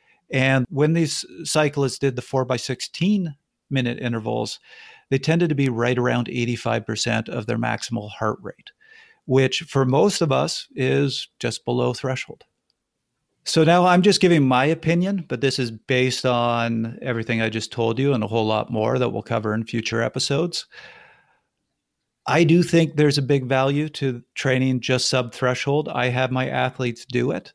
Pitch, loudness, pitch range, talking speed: 130 Hz, -21 LUFS, 120-150 Hz, 170 wpm